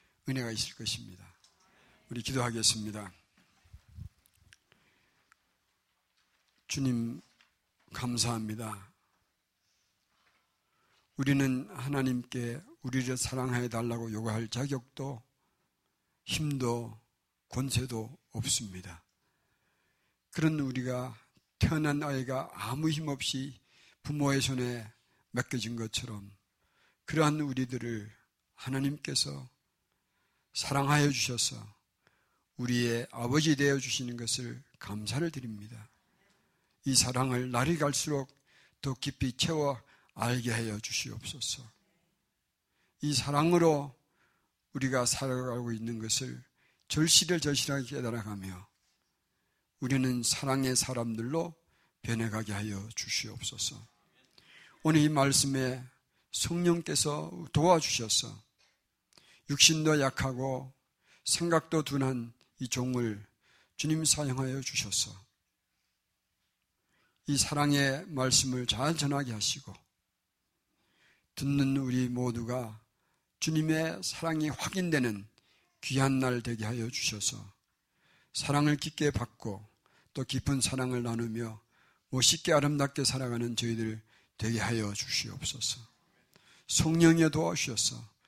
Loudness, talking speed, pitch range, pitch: -31 LUFS, 215 characters per minute, 115-140 Hz, 125 Hz